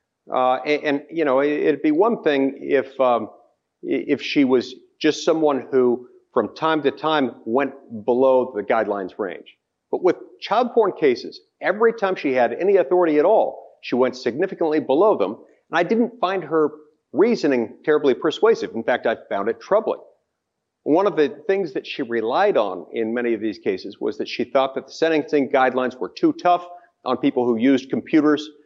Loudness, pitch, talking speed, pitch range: -21 LUFS, 150 Hz, 180 wpm, 130-215 Hz